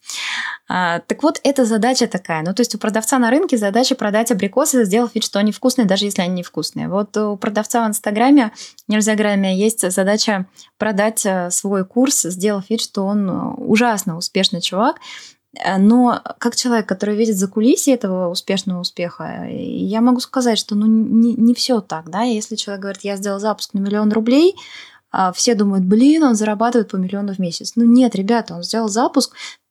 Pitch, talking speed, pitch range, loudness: 215 Hz, 180 wpm, 195-240 Hz, -17 LUFS